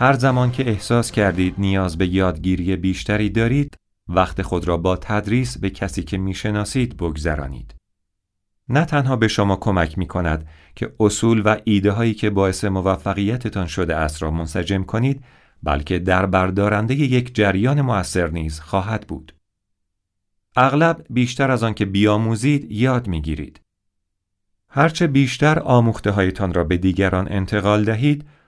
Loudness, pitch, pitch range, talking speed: -19 LUFS, 100 Hz, 95-115 Hz, 140 wpm